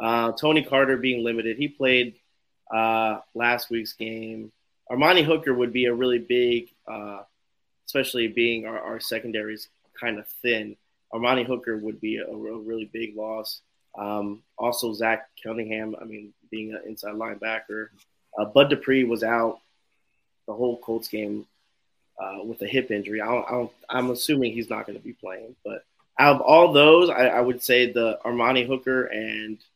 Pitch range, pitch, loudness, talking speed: 110-125 Hz, 115 Hz, -23 LUFS, 170 wpm